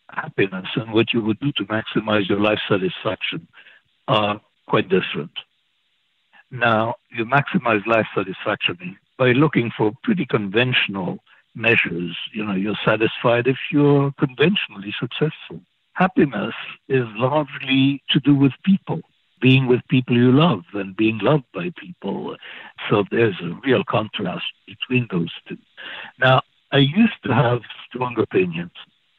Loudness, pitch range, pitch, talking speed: -20 LUFS, 110-145 Hz, 125 Hz, 135 wpm